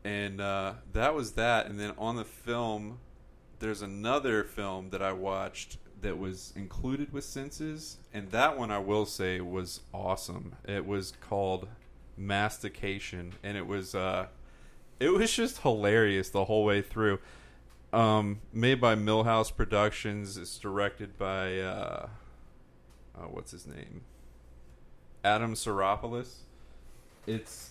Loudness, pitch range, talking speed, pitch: -32 LUFS, 95-110 Hz, 130 wpm, 100 Hz